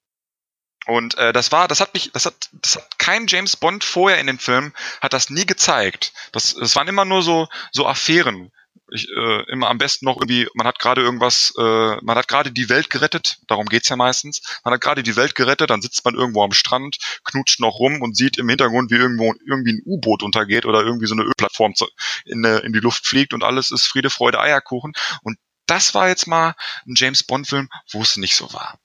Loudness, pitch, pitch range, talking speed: -17 LUFS, 130 Hz, 115-150 Hz, 225 wpm